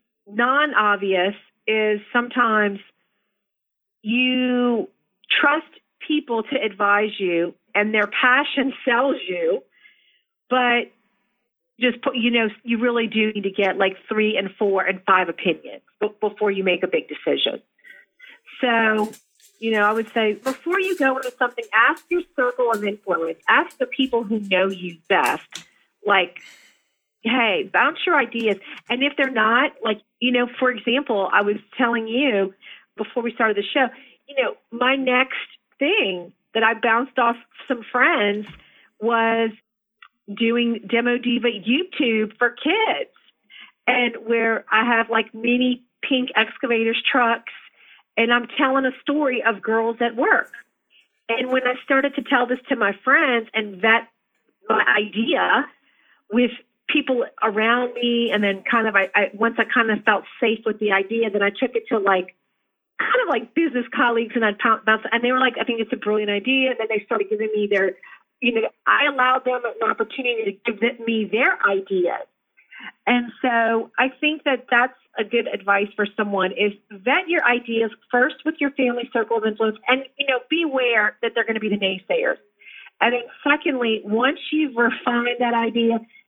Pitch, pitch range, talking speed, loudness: 235 Hz, 215-255 Hz, 165 wpm, -20 LUFS